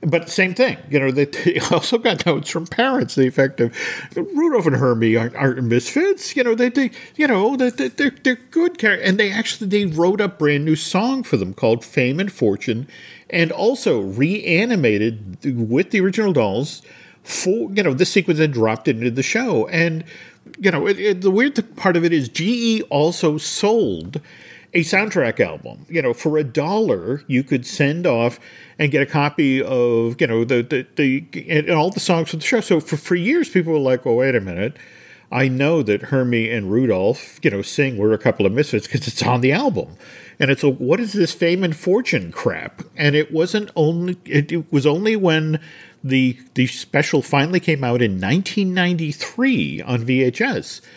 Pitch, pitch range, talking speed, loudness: 160 Hz, 135-195 Hz, 195 wpm, -19 LUFS